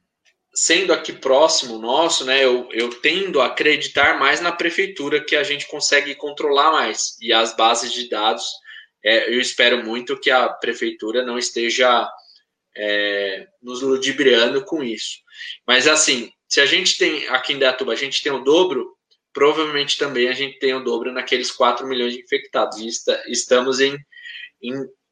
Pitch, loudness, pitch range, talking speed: 140 Hz, -18 LUFS, 120-185 Hz, 165 wpm